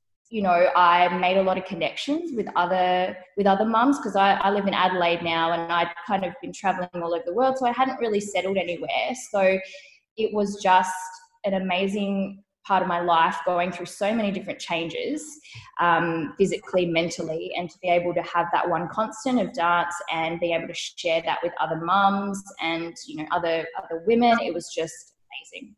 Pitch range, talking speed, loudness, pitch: 170-200 Hz, 200 wpm, -24 LUFS, 185 Hz